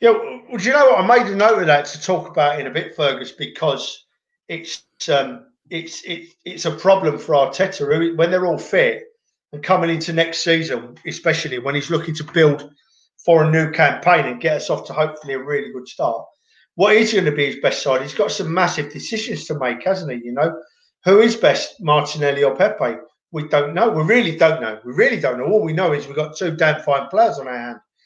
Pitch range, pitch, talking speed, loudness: 145-200 Hz, 165 Hz, 230 wpm, -18 LUFS